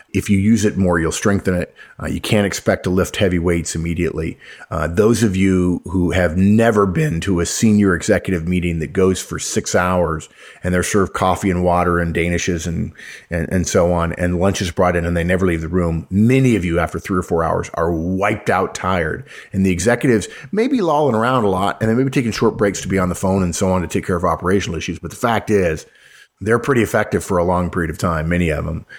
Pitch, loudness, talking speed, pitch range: 90 Hz, -18 LUFS, 240 wpm, 85-100 Hz